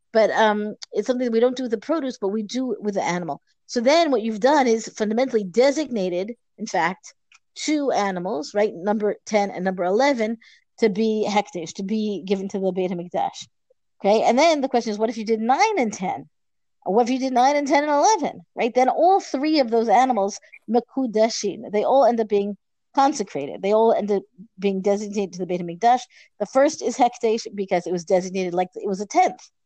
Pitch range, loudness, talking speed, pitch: 200-255 Hz, -22 LUFS, 210 wpm, 220 Hz